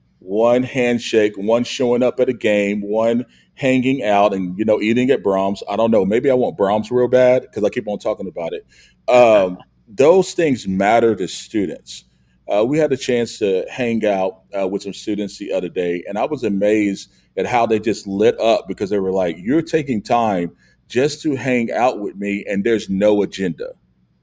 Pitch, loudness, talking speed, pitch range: 110 Hz, -18 LUFS, 200 wpm, 100-125 Hz